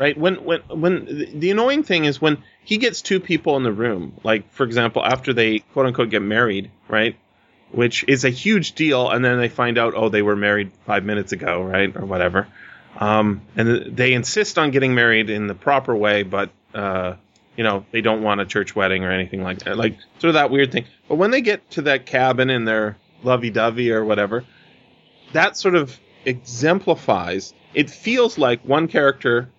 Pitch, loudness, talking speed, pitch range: 120 Hz, -19 LUFS, 200 wpm, 105-150 Hz